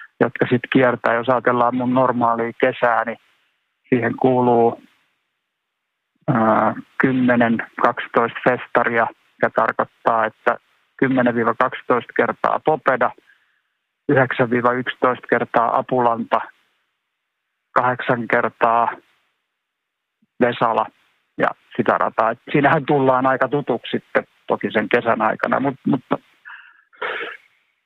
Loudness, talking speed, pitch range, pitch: -19 LUFS, 90 wpm, 115-130 Hz, 125 Hz